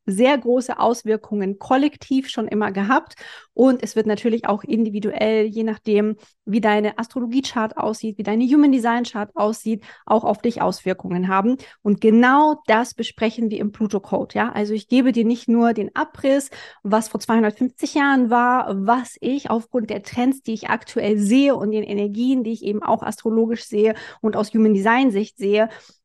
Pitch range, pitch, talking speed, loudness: 210-245 Hz, 225 Hz, 165 wpm, -20 LUFS